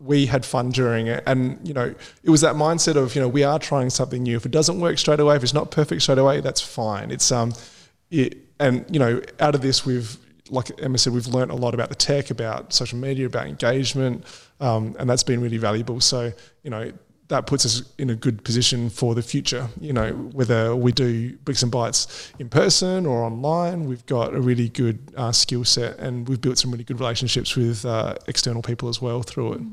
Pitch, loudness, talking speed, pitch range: 125 Hz, -21 LUFS, 230 wpm, 120-140 Hz